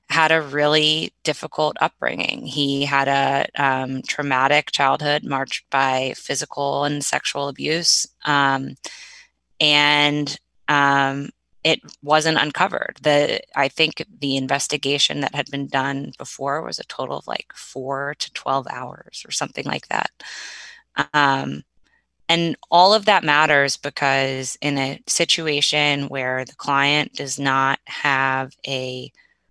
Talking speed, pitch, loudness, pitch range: 130 wpm, 140 Hz, -20 LUFS, 135-150 Hz